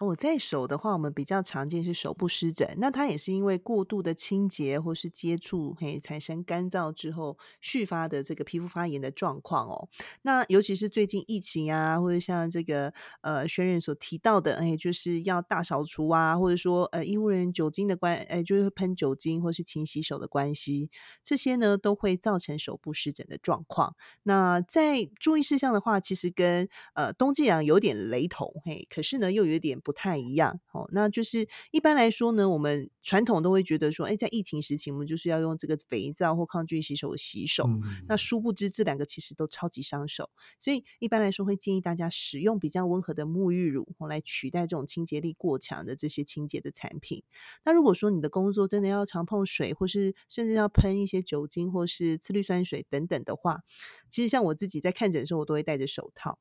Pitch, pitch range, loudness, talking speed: 175 Hz, 155-200 Hz, -29 LUFS, 320 characters per minute